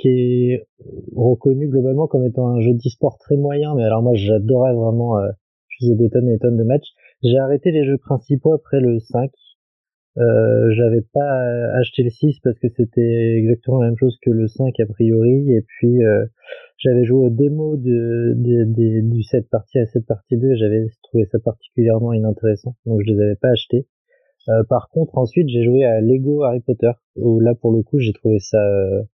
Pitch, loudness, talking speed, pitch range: 120 Hz, -17 LUFS, 195 wpm, 115-130 Hz